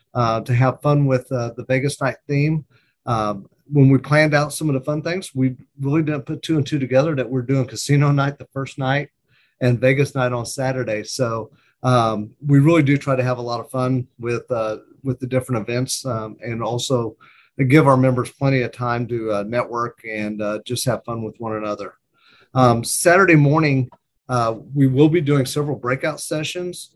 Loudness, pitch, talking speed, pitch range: -20 LUFS, 130 Hz, 205 wpm, 120-145 Hz